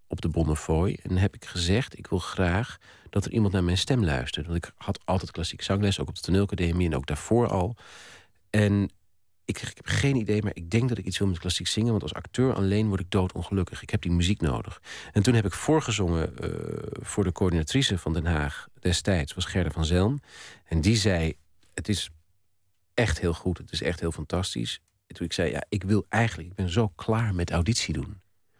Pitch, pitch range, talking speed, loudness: 95 Hz, 85-105 Hz, 220 wpm, -27 LUFS